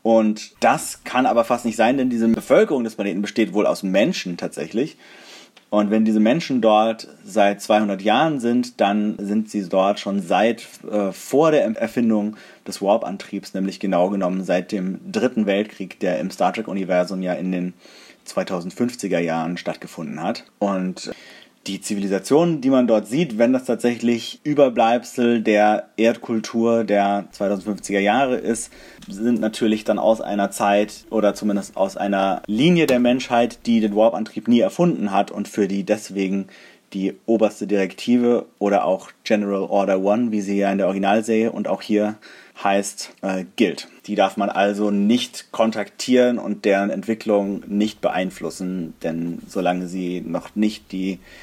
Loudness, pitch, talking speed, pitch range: -20 LUFS, 105 Hz, 155 wpm, 100-115 Hz